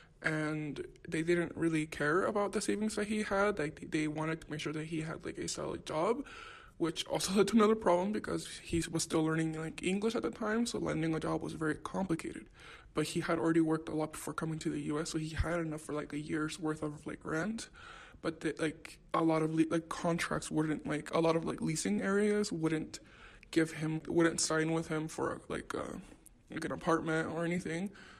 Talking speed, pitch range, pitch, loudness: 215 wpm, 155-170 Hz, 160 Hz, -35 LUFS